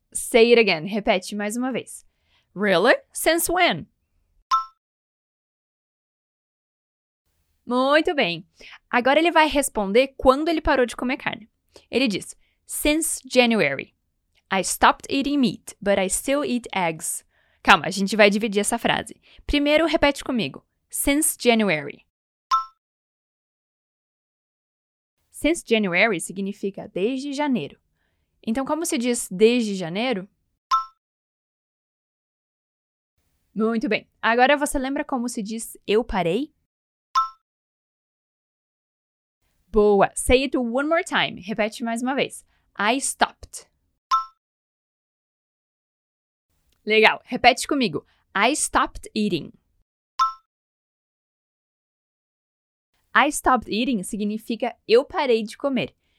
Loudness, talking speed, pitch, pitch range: -22 LUFS, 100 wpm, 245 Hz, 215-280 Hz